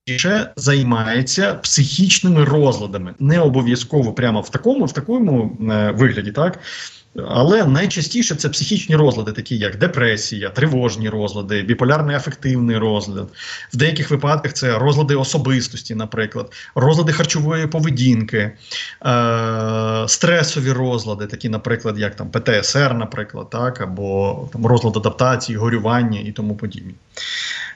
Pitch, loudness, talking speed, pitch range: 125 Hz, -17 LUFS, 120 wpm, 110-150 Hz